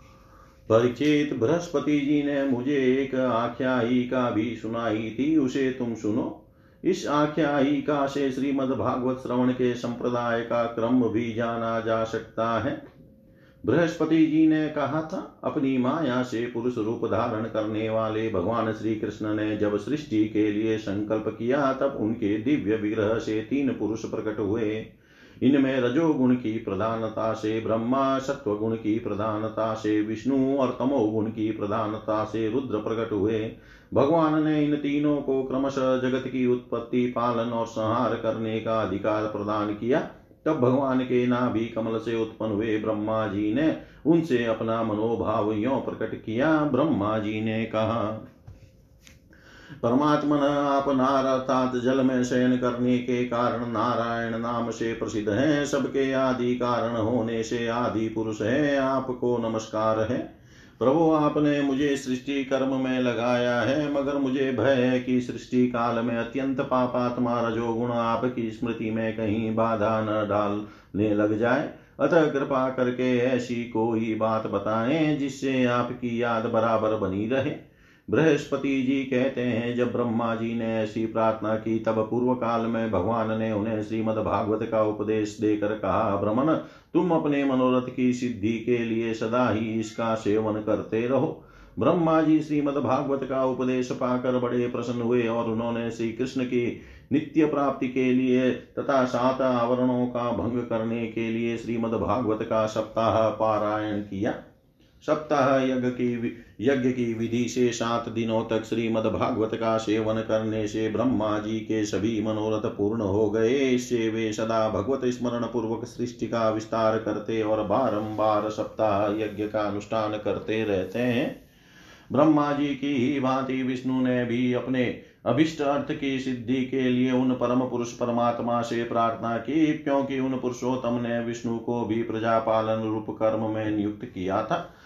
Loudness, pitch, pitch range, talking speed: -26 LUFS, 115 Hz, 110-130 Hz, 150 wpm